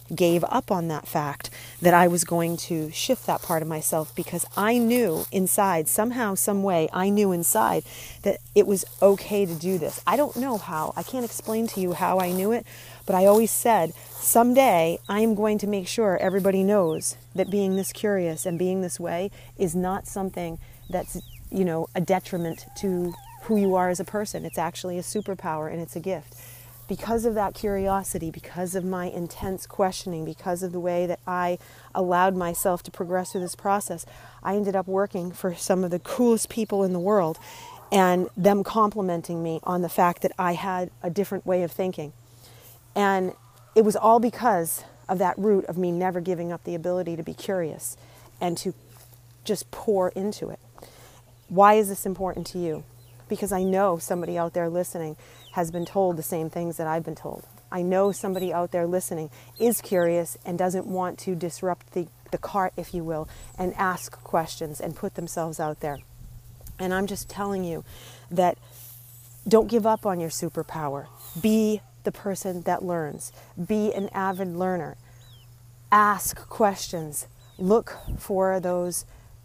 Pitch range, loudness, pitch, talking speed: 160-195 Hz, -25 LUFS, 180 Hz, 180 wpm